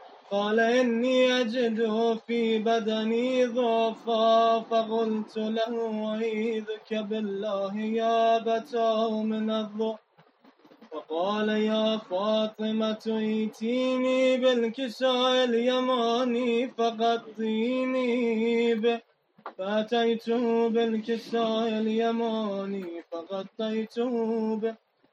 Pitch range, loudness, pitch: 220-235 Hz, -27 LUFS, 225 Hz